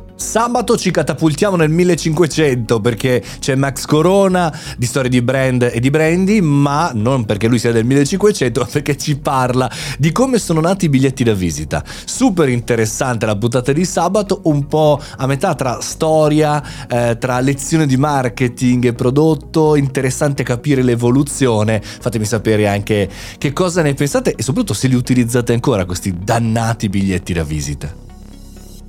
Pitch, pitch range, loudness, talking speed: 130 Hz, 115-155 Hz, -15 LUFS, 155 wpm